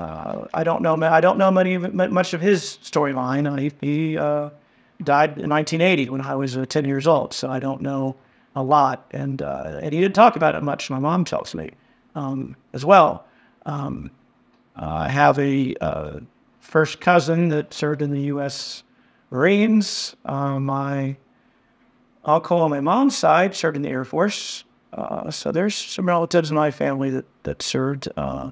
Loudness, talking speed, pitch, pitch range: -21 LUFS, 175 wpm, 150 Hz, 135-175 Hz